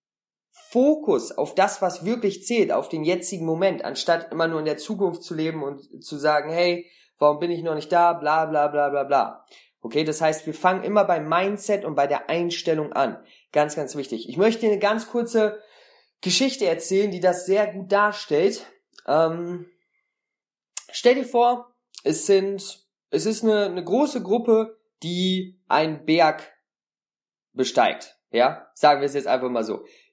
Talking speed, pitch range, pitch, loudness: 170 wpm, 155-215 Hz, 180 Hz, -23 LUFS